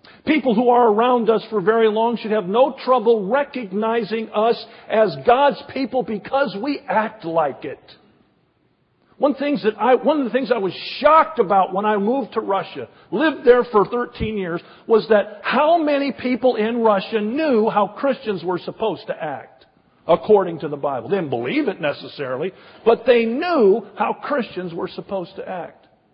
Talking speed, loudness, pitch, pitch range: 170 wpm, -19 LUFS, 225 Hz, 200-255 Hz